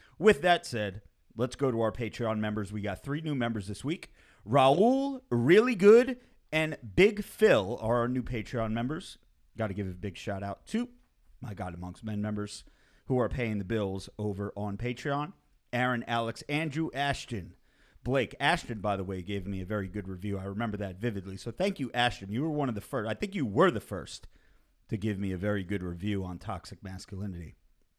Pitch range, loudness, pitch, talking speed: 100-135 Hz, -30 LUFS, 110 Hz, 200 wpm